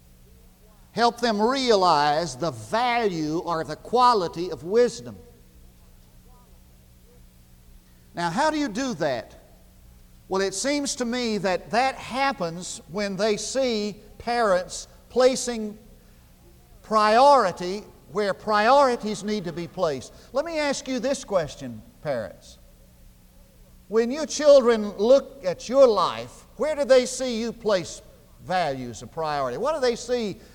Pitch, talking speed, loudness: 195 Hz, 125 wpm, -23 LUFS